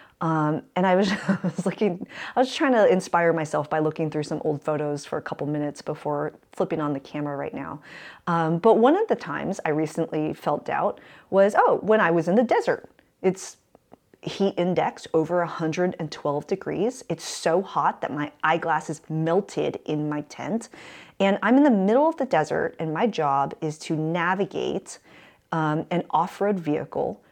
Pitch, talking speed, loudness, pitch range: 165 Hz, 180 wpm, -24 LUFS, 155-195 Hz